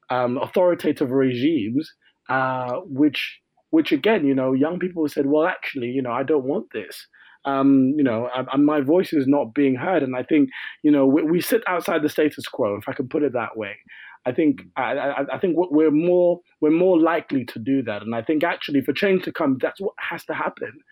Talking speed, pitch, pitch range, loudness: 220 wpm, 150 Hz, 135-175 Hz, -21 LUFS